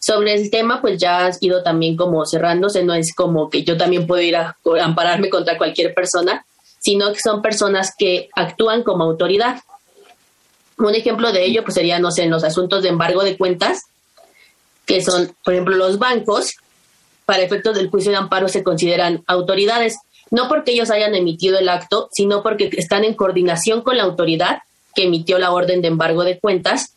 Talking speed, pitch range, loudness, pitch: 185 wpm, 175-210 Hz, -17 LUFS, 185 Hz